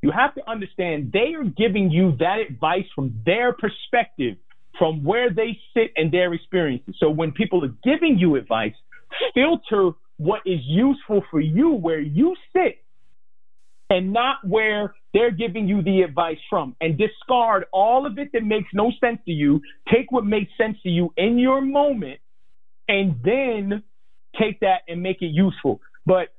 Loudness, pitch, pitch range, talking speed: -21 LUFS, 205 Hz, 175-240 Hz, 170 wpm